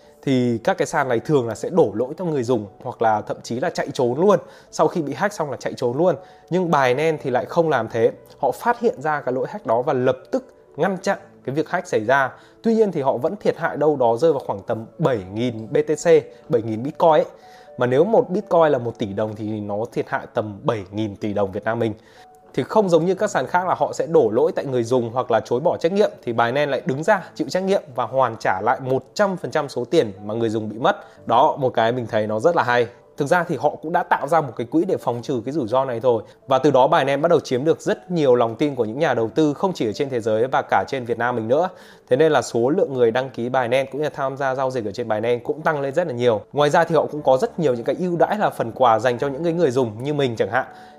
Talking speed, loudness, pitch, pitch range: 290 wpm, -21 LUFS, 135 Hz, 120-170 Hz